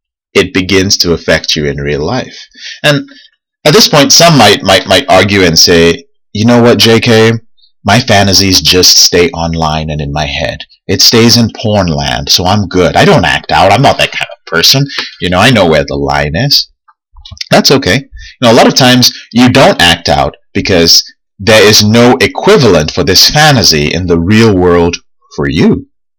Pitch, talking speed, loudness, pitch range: 100 Hz, 195 wpm, -6 LUFS, 85-120 Hz